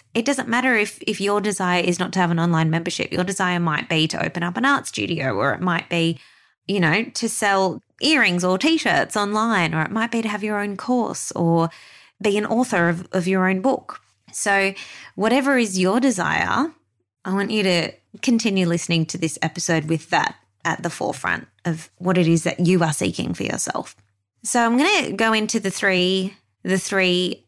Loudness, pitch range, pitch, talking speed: -21 LUFS, 170-225 Hz, 190 Hz, 200 wpm